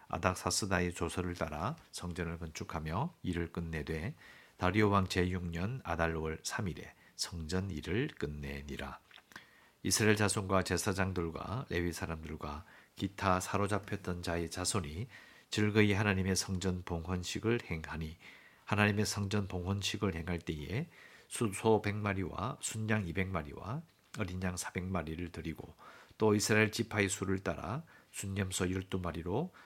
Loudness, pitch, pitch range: -35 LUFS, 95 Hz, 85-105 Hz